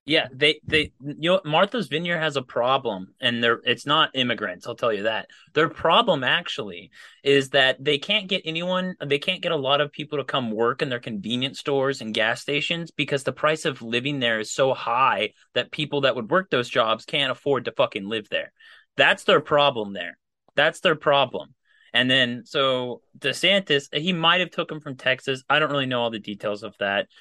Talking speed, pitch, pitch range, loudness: 205 wpm, 140 Hz, 125-155 Hz, -23 LUFS